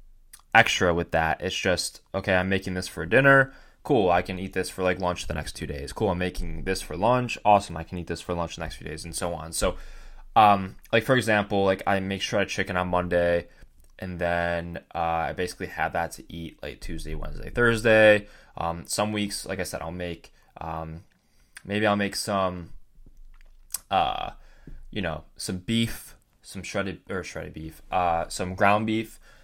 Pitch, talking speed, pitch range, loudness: 90 Hz, 195 wpm, 85-100 Hz, -25 LUFS